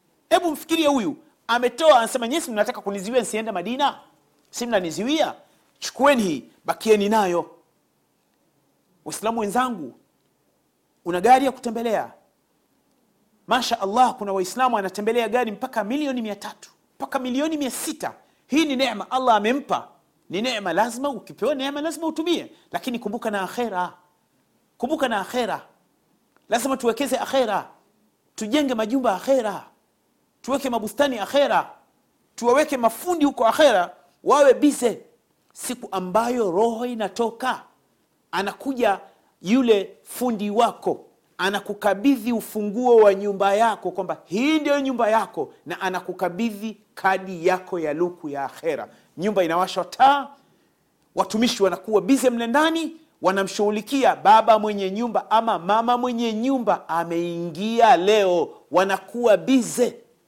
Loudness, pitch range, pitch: -22 LUFS, 200-265 Hz, 230 Hz